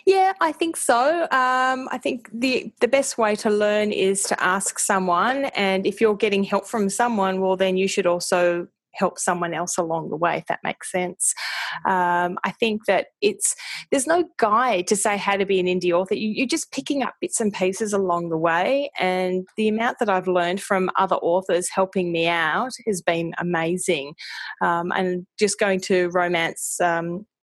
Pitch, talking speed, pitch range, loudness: 195 Hz, 190 wpm, 180-235 Hz, -22 LUFS